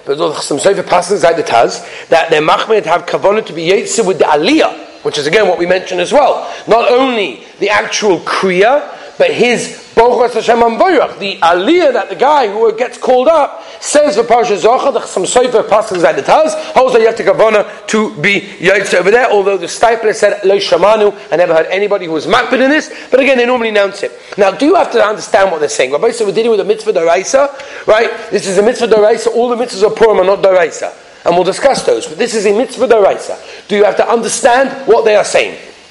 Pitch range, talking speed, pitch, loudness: 200-280 Hz, 205 wpm, 230 Hz, -11 LUFS